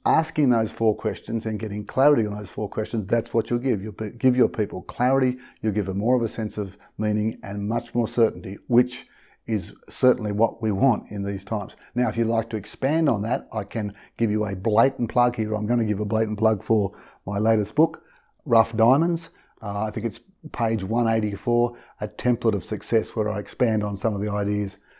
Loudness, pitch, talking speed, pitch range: -24 LUFS, 110 Hz, 215 wpm, 105-120 Hz